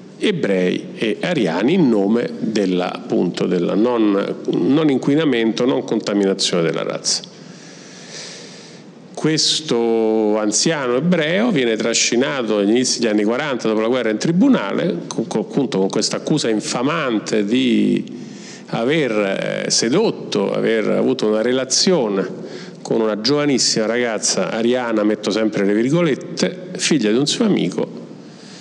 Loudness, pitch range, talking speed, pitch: -18 LUFS, 105-125 Hz, 120 wpm, 110 Hz